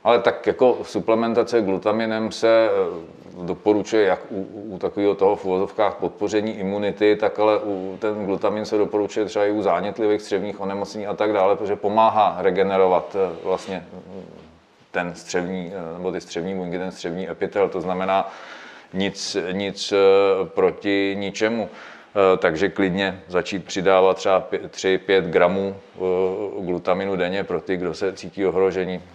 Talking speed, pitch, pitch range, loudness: 135 wpm, 100 Hz, 95-105 Hz, -22 LUFS